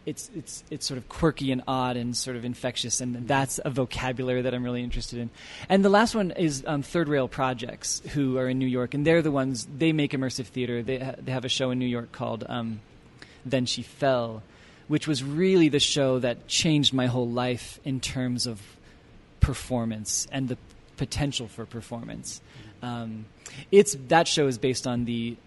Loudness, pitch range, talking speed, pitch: -26 LUFS, 120-140 Hz, 200 wpm, 130 Hz